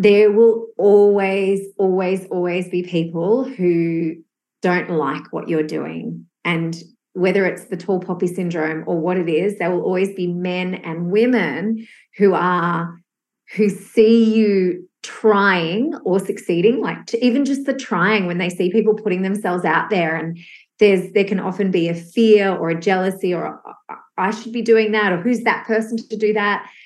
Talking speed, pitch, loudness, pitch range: 175 wpm, 190 Hz, -18 LUFS, 175-215 Hz